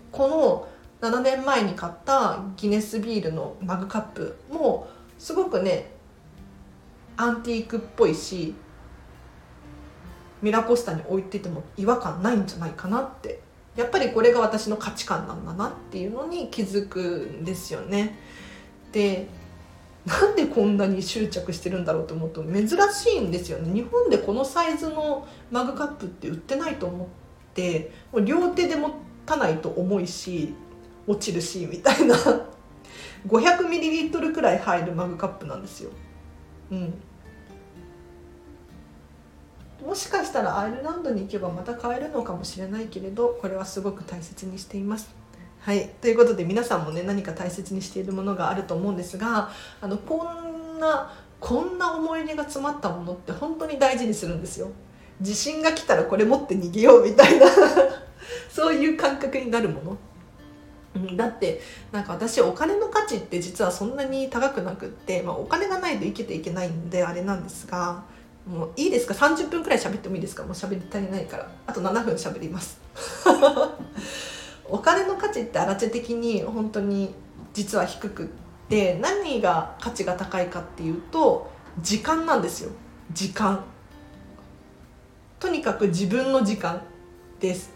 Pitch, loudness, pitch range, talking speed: 205 Hz, -24 LUFS, 180-275 Hz, 320 characters per minute